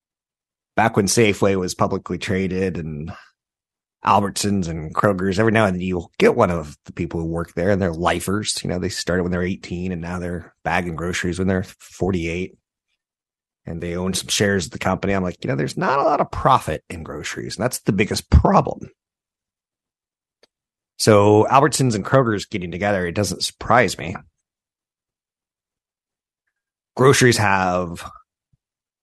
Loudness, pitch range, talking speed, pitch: -20 LUFS, 85-100 Hz, 160 wpm, 95 Hz